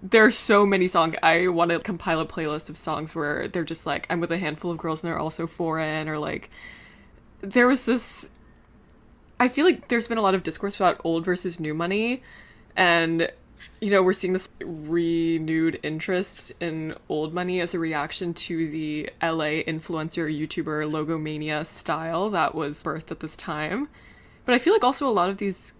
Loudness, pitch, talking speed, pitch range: -24 LUFS, 165 Hz, 190 wpm, 155-190 Hz